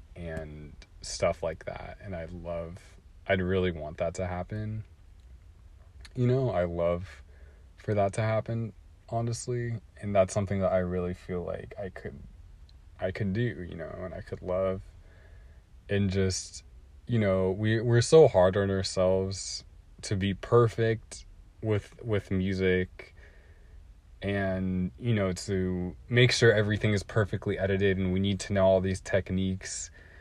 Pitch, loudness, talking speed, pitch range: 95 Hz, -29 LUFS, 150 wpm, 85-100 Hz